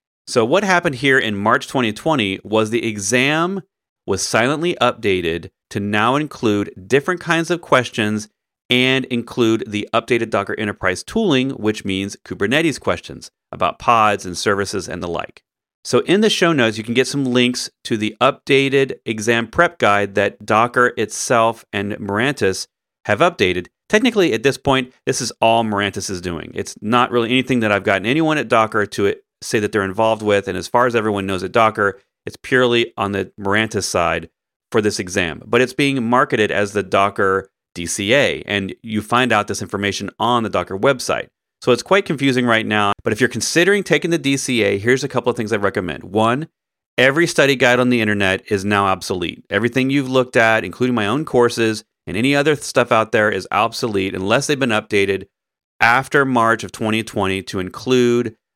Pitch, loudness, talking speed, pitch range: 115 Hz, -17 LUFS, 185 wpm, 100-130 Hz